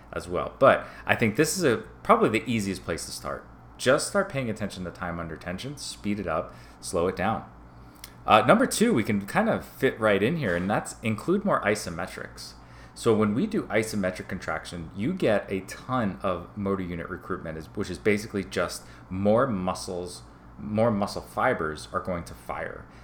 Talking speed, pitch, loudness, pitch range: 185 wpm, 95 Hz, -27 LUFS, 85-105 Hz